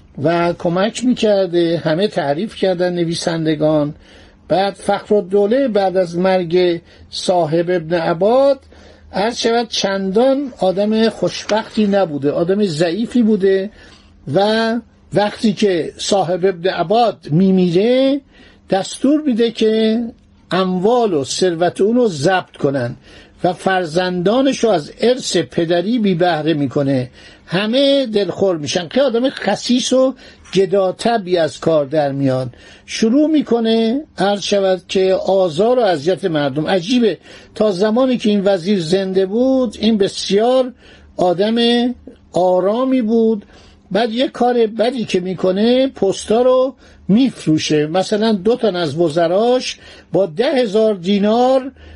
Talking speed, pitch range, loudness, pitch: 120 wpm, 180-230 Hz, -16 LUFS, 195 Hz